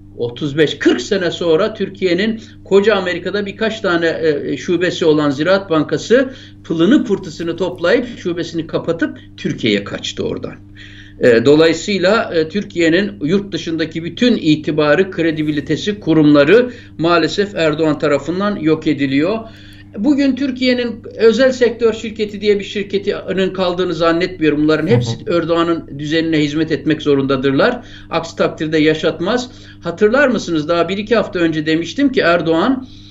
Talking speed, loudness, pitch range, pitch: 115 wpm, -15 LUFS, 155-200 Hz, 170 Hz